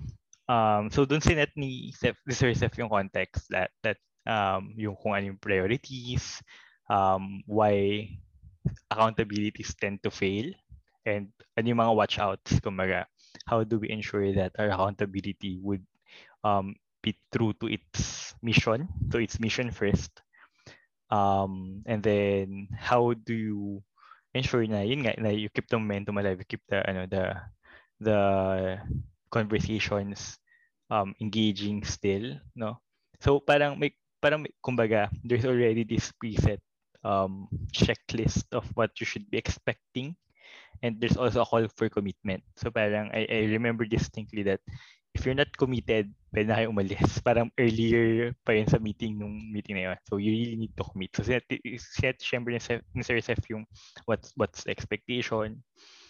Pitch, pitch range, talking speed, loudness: 110 Hz, 100-120 Hz, 140 wpm, -29 LUFS